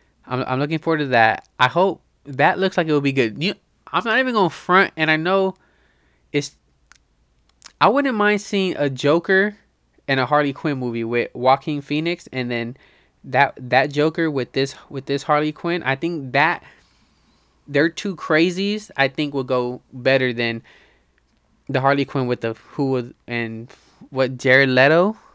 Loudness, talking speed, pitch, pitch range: -20 LUFS, 170 wpm, 140 Hz, 125-170 Hz